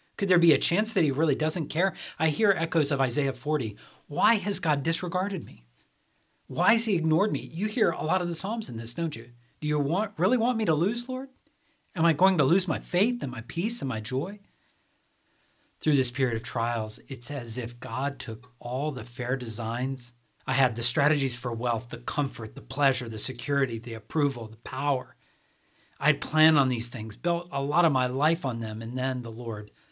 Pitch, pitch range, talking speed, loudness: 140 Hz, 120-170 Hz, 215 wpm, -27 LUFS